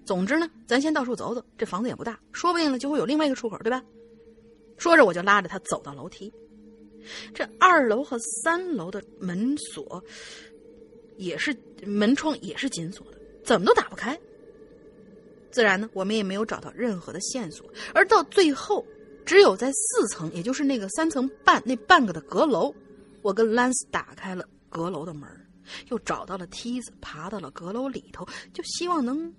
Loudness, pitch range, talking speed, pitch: -24 LUFS, 205-275 Hz, 265 characters per minute, 230 Hz